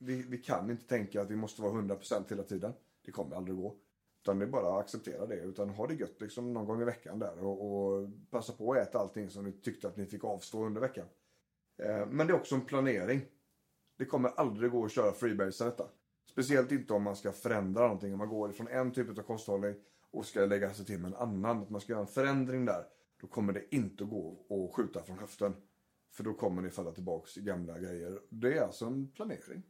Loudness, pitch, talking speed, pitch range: -36 LUFS, 105 Hz, 240 wpm, 100-120 Hz